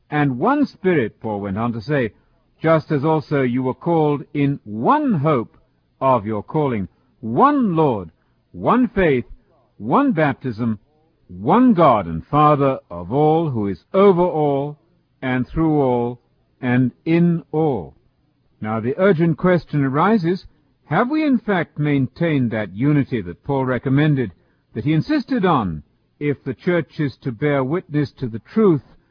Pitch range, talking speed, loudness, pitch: 120-165 Hz, 145 wpm, -19 LUFS, 145 Hz